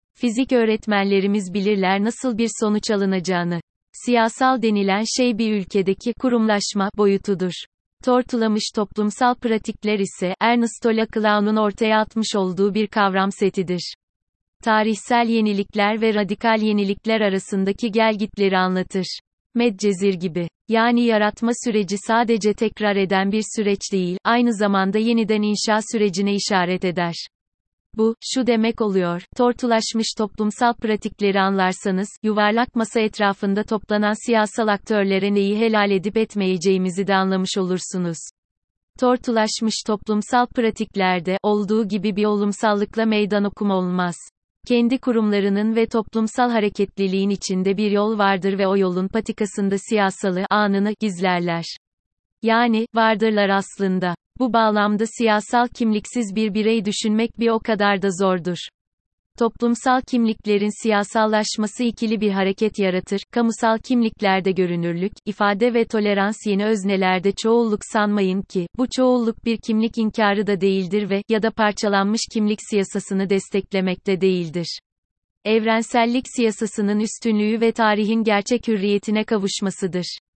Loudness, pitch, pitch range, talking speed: -20 LUFS, 210 Hz, 195-225 Hz, 115 wpm